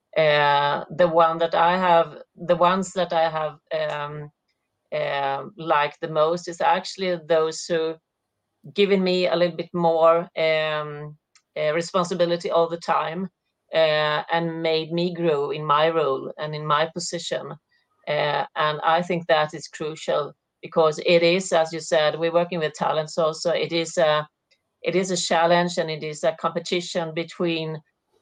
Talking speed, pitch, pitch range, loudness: 160 wpm, 165 Hz, 155-175 Hz, -23 LUFS